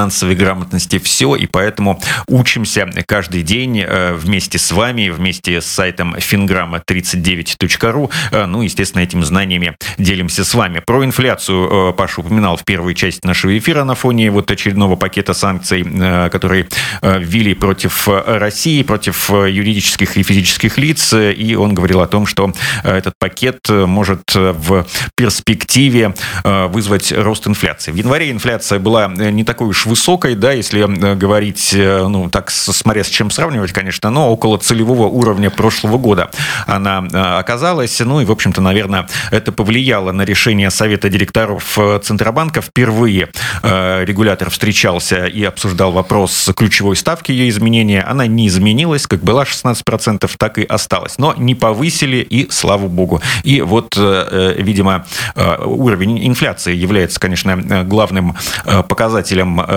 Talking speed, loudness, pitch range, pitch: 135 wpm, -13 LUFS, 95-115 Hz, 100 Hz